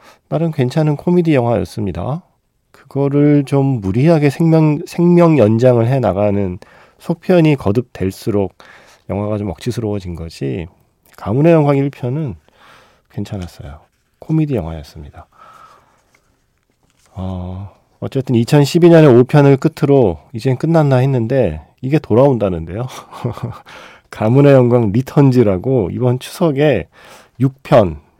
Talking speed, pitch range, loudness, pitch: 250 characters per minute, 105-145 Hz, -14 LUFS, 125 Hz